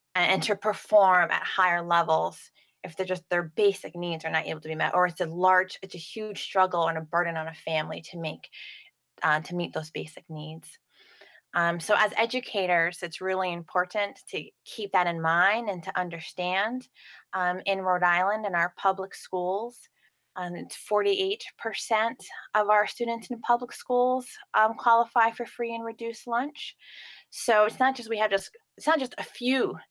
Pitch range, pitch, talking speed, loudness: 175-225 Hz, 190 Hz, 185 wpm, -27 LUFS